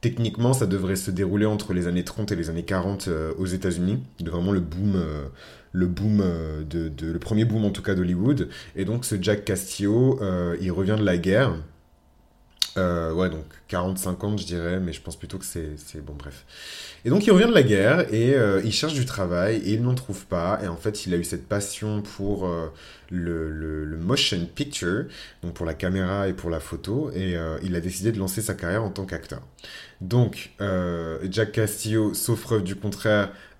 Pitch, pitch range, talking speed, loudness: 95 Hz, 85-105 Hz, 215 wpm, -25 LUFS